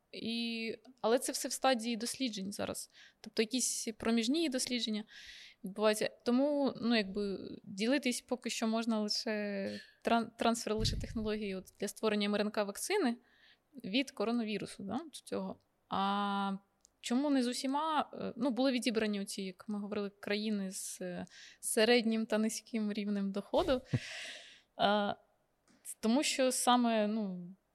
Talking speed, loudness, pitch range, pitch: 130 wpm, -35 LUFS, 205-250 Hz, 225 Hz